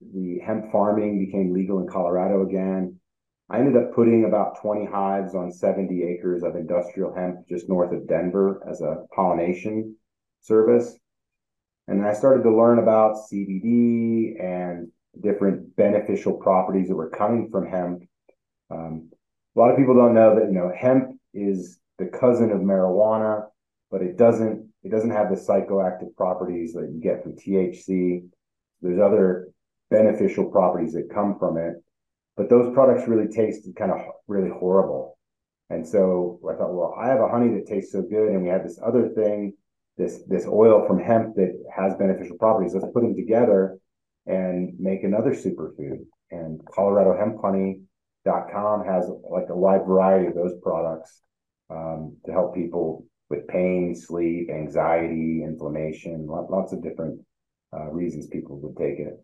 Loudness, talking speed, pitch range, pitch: -22 LUFS, 160 wpm, 90-110 Hz, 95 Hz